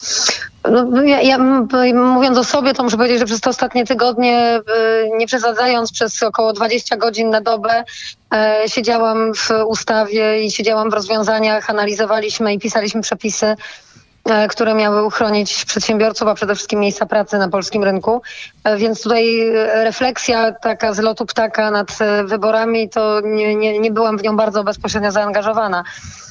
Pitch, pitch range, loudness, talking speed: 220 Hz, 215-230 Hz, -15 LUFS, 145 wpm